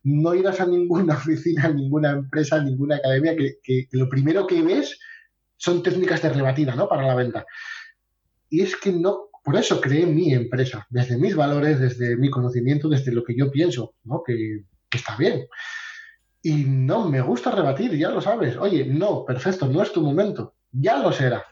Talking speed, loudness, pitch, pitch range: 190 wpm, -22 LUFS, 145 Hz, 130-175 Hz